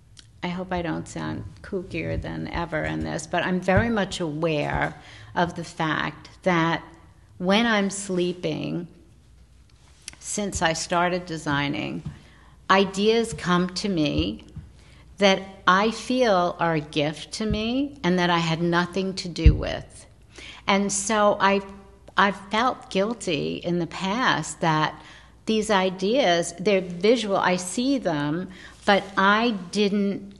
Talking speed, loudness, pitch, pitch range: 130 wpm, -24 LUFS, 180 Hz, 165-200 Hz